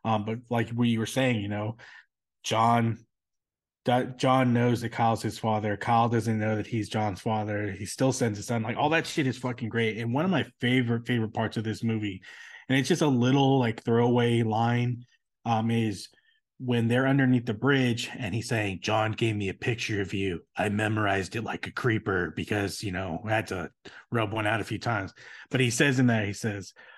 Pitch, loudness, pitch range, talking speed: 115 Hz, -27 LUFS, 105-125 Hz, 215 wpm